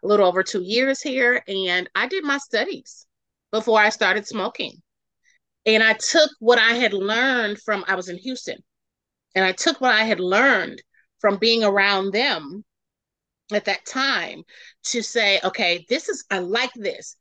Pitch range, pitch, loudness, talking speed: 200-255 Hz, 220 Hz, -20 LUFS, 170 wpm